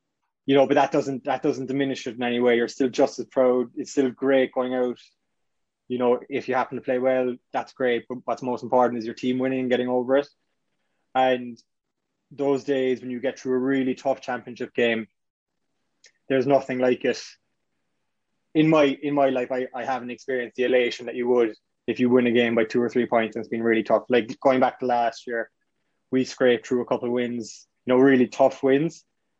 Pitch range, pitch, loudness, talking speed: 120-135 Hz, 125 Hz, -23 LUFS, 220 wpm